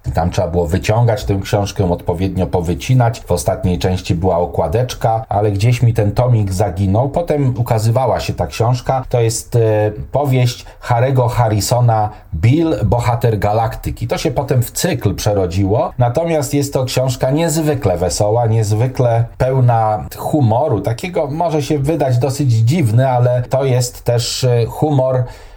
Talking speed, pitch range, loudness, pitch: 140 wpm, 105-130 Hz, -15 LUFS, 115 Hz